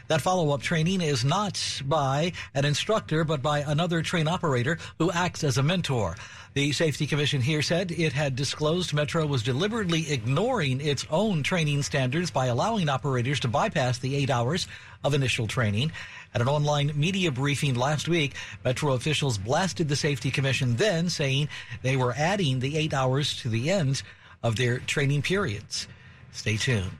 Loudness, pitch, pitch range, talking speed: -26 LUFS, 145 Hz, 125-160 Hz, 170 wpm